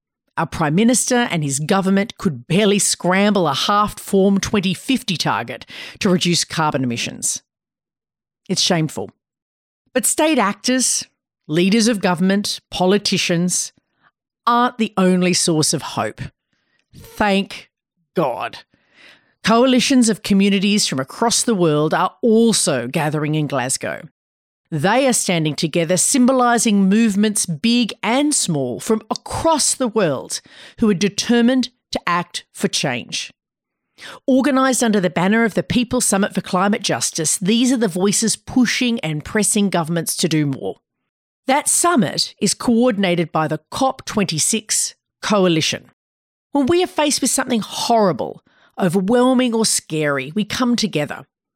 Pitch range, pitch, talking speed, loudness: 170-235 Hz, 200 Hz, 130 wpm, -17 LUFS